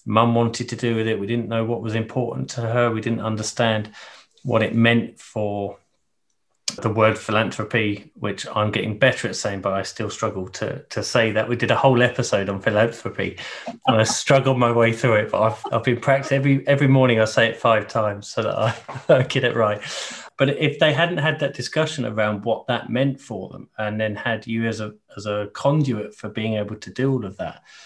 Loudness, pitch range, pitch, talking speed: -21 LUFS, 105-125 Hz, 115 Hz, 220 wpm